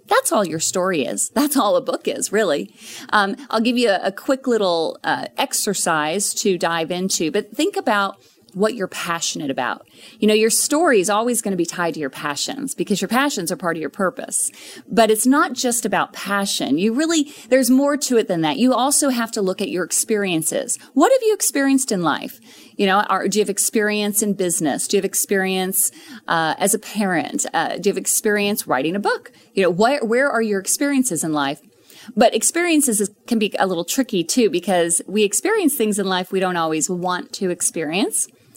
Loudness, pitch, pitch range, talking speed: -19 LUFS, 210 Hz, 185-260 Hz, 210 wpm